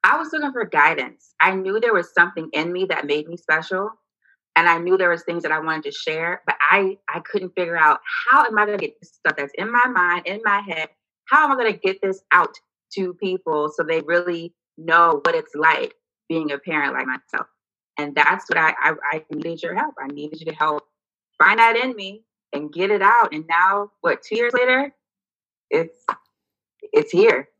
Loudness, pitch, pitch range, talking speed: -19 LUFS, 190 Hz, 160-230 Hz, 220 wpm